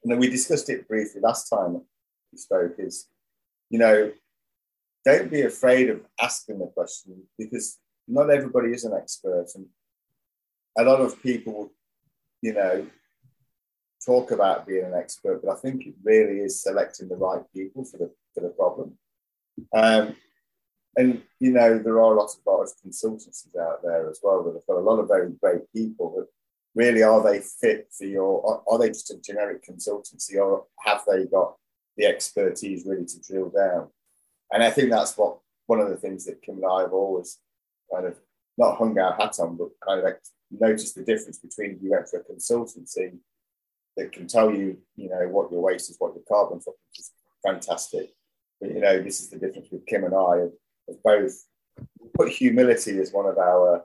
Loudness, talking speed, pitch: -24 LUFS, 195 wpm, 125 Hz